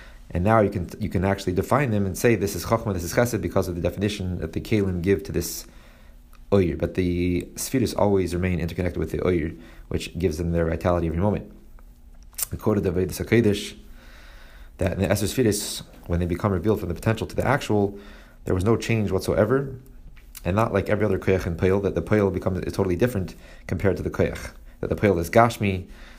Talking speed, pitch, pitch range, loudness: 210 wpm, 95 Hz, 85-105 Hz, -24 LUFS